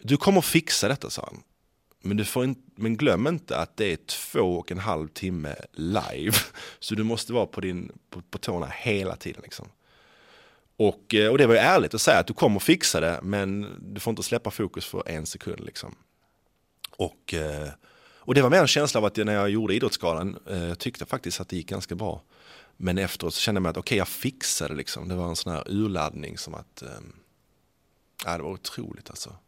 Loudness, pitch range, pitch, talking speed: -26 LUFS, 85-110 Hz, 100 Hz, 205 wpm